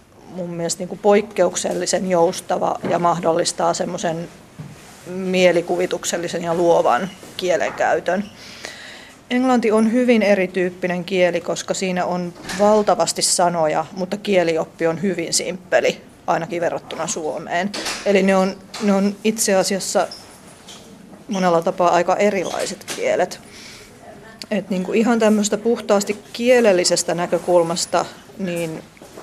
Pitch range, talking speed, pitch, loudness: 175-205 Hz, 105 wpm, 185 Hz, -19 LUFS